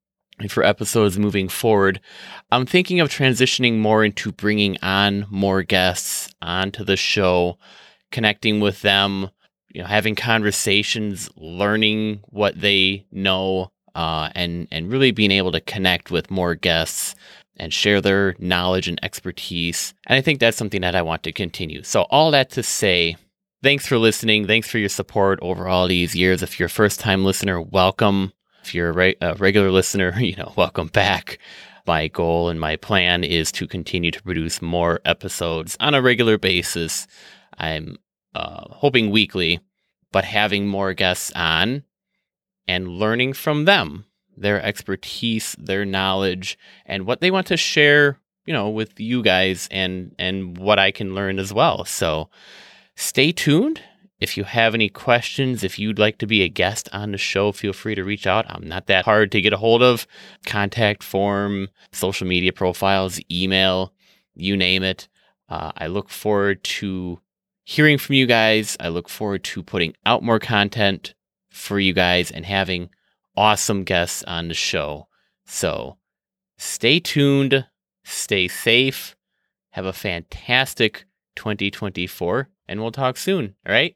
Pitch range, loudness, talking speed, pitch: 90-110 Hz, -19 LUFS, 160 wpm, 100 Hz